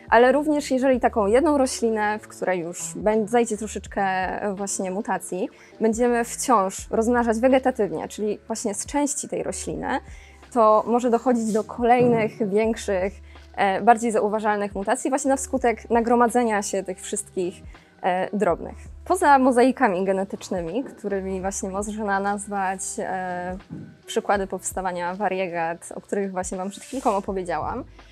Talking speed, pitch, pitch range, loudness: 120 wpm, 210 Hz, 190-240 Hz, -23 LUFS